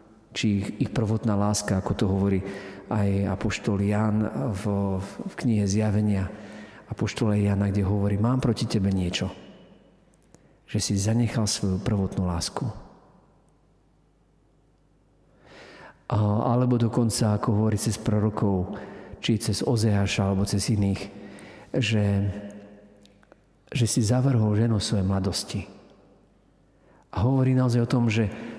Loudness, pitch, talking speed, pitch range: -25 LUFS, 105 Hz, 115 wpm, 100-115 Hz